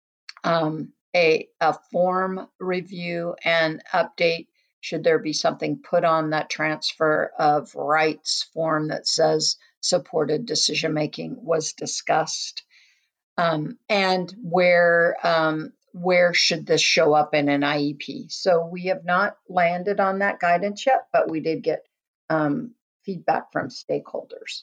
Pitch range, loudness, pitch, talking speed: 155-185 Hz, -22 LUFS, 170 Hz, 130 wpm